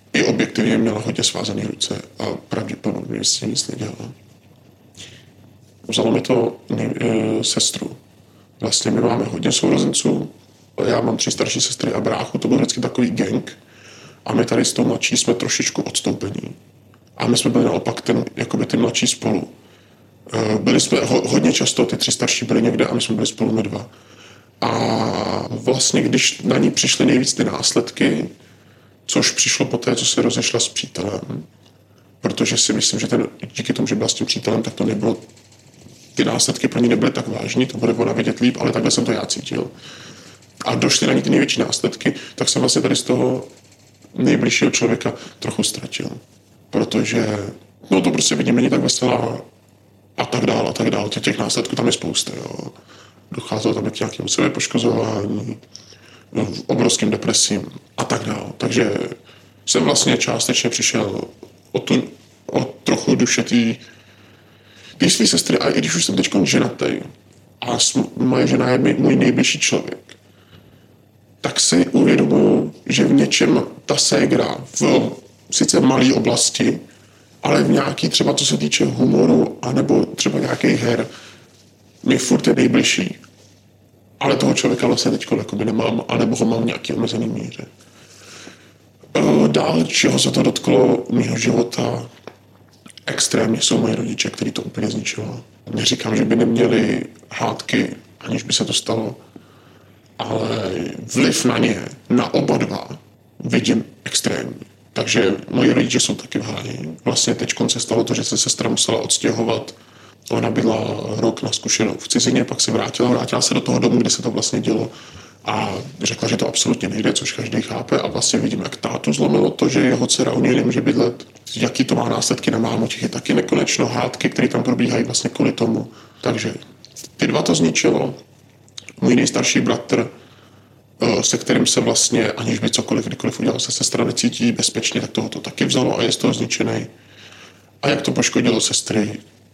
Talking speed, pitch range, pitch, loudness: 165 wpm, 105-120 Hz, 115 Hz, -18 LUFS